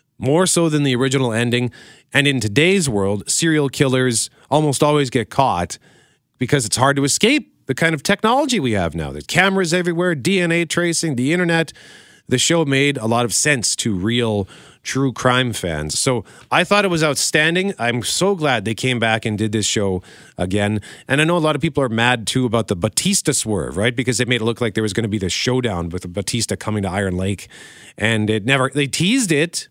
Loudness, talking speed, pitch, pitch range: -18 LUFS, 210 wpm, 130 Hz, 110-155 Hz